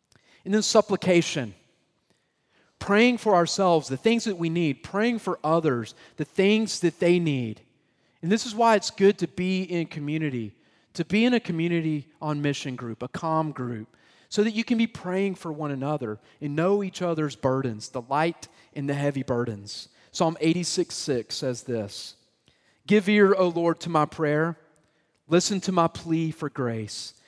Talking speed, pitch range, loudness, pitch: 170 wpm, 135-185 Hz, -25 LUFS, 160 Hz